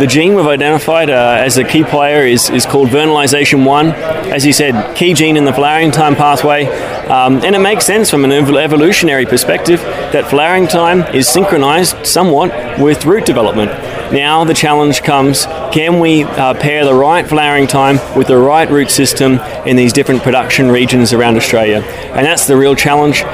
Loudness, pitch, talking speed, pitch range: -9 LUFS, 145 Hz, 185 wpm, 135-160 Hz